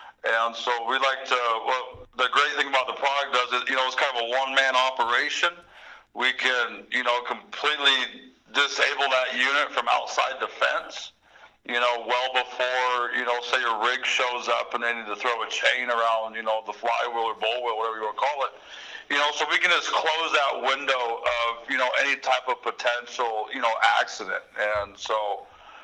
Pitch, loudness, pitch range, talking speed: 125 Hz, -24 LUFS, 115-130 Hz, 200 wpm